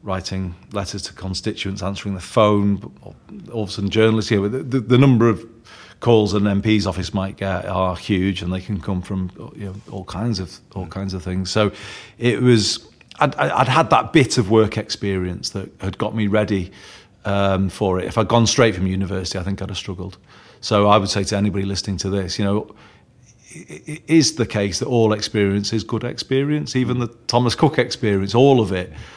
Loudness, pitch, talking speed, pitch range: -19 LUFS, 105 Hz, 205 wpm, 95-115 Hz